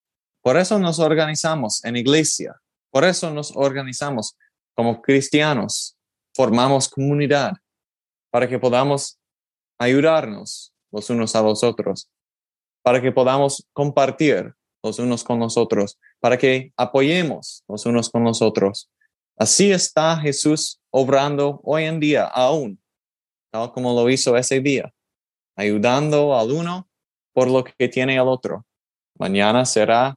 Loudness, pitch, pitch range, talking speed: -19 LUFS, 135 Hz, 120-150 Hz, 130 wpm